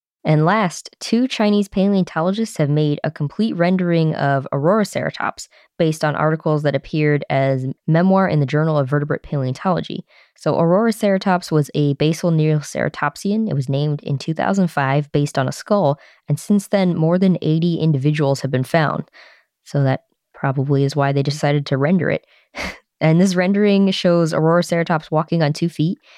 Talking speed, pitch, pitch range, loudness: 165 wpm, 160 Hz, 145-185 Hz, -18 LUFS